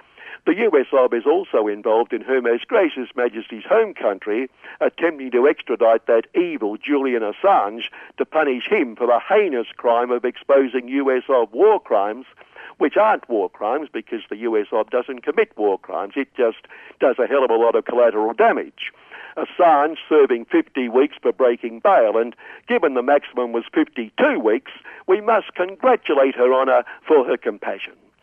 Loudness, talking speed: -19 LUFS, 165 wpm